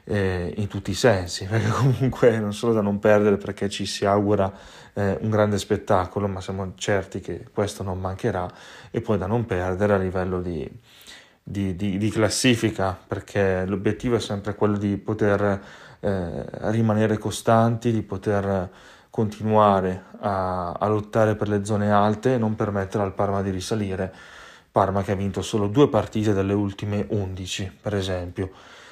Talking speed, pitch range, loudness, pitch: 155 wpm, 95-110 Hz, -24 LUFS, 100 Hz